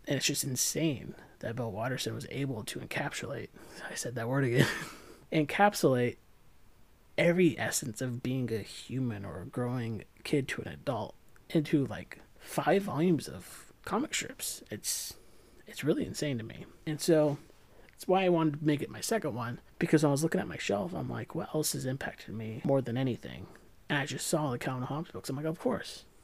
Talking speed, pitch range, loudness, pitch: 195 wpm, 120-155 Hz, -32 LUFS, 135 Hz